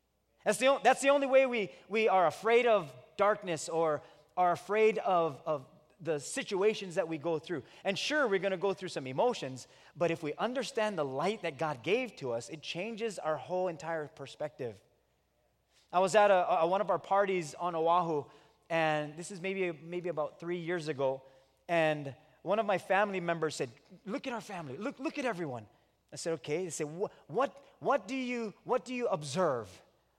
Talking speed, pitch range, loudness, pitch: 195 wpm, 155-215 Hz, -32 LUFS, 175 Hz